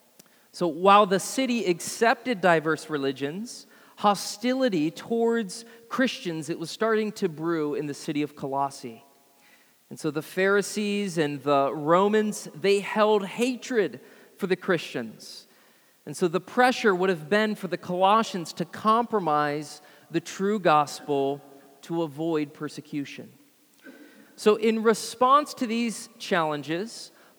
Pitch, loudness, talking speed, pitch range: 190 Hz, -25 LUFS, 125 wpm, 155-225 Hz